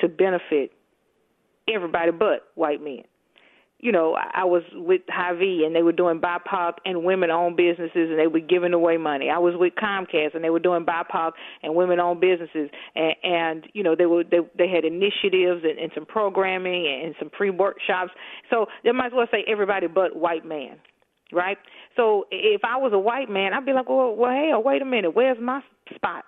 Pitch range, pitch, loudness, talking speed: 170-210 Hz, 180 Hz, -23 LUFS, 200 wpm